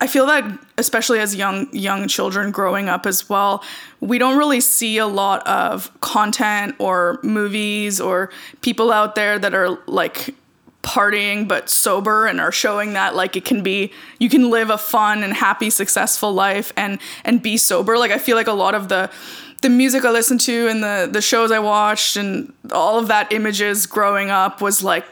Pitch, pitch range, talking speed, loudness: 210 Hz, 200-240 Hz, 195 wpm, -17 LUFS